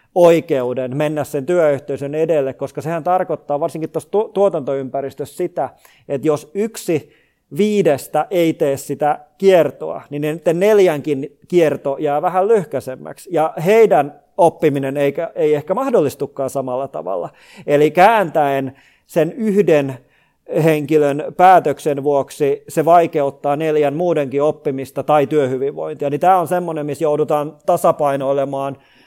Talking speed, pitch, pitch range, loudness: 115 wpm, 150 Hz, 140-170 Hz, -17 LUFS